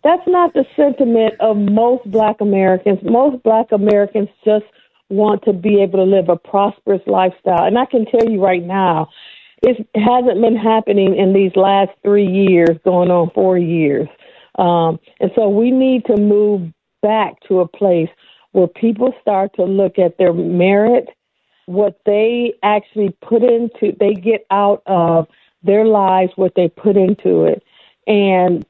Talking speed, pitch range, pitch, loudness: 160 wpm, 185-225 Hz, 205 Hz, -14 LUFS